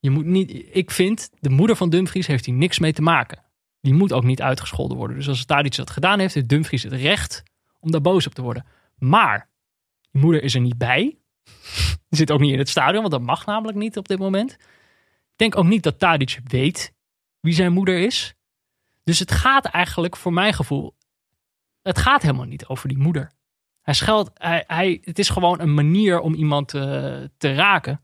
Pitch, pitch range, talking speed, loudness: 160 Hz, 135-185 Hz, 210 wpm, -20 LUFS